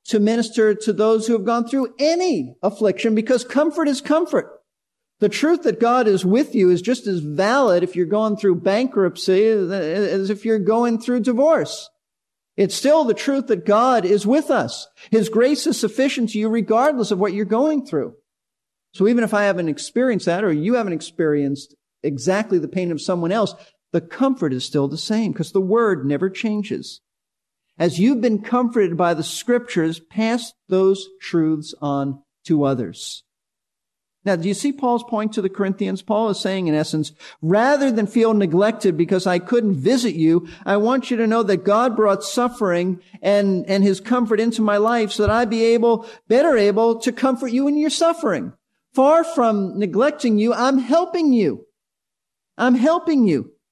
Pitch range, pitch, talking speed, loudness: 190-245 Hz, 215 Hz, 180 wpm, -19 LUFS